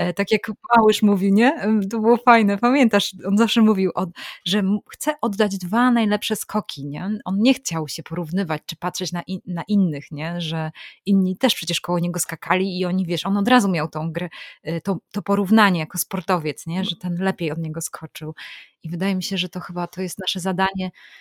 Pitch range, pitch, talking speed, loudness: 175-210 Hz, 190 Hz, 195 wpm, -21 LUFS